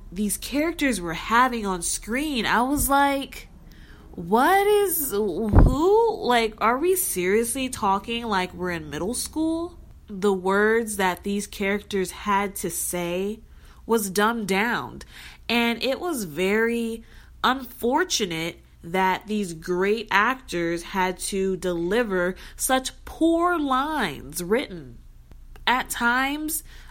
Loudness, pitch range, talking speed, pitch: -23 LUFS, 185-260 Hz, 115 wpm, 215 Hz